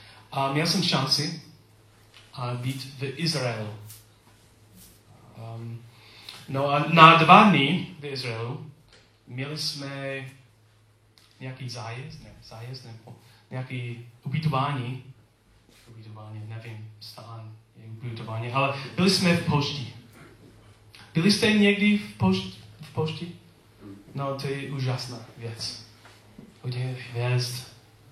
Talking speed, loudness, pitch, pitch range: 100 wpm, -24 LUFS, 120 Hz, 110-140 Hz